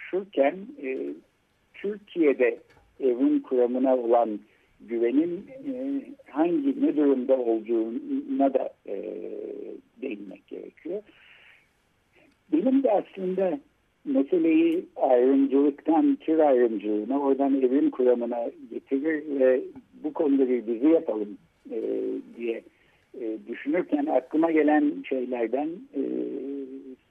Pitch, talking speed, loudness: 150 Hz, 75 wpm, -26 LUFS